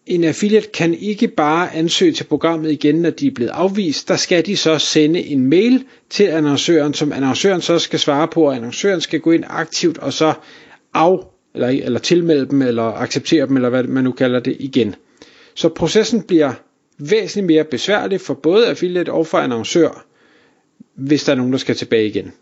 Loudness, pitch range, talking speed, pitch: -16 LUFS, 135-180 Hz, 195 wpm, 155 Hz